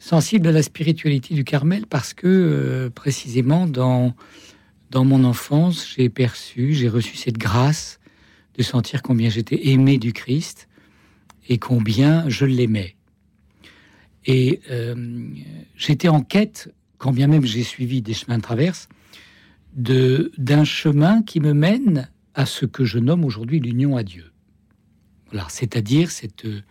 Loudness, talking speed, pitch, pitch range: -19 LUFS, 140 wpm, 130 Hz, 115-150 Hz